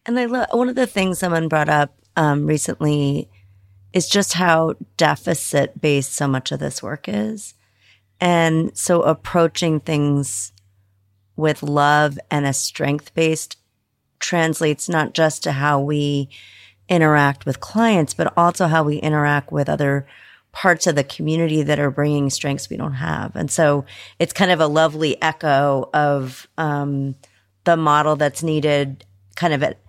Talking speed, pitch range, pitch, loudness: 155 wpm, 135-160 Hz, 150 Hz, -19 LUFS